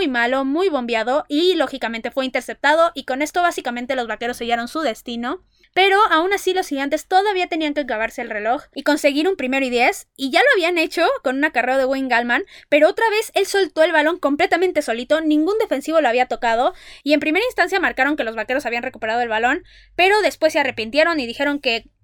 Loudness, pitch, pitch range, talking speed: -19 LUFS, 295 Hz, 250-345 Hz, 210 wpm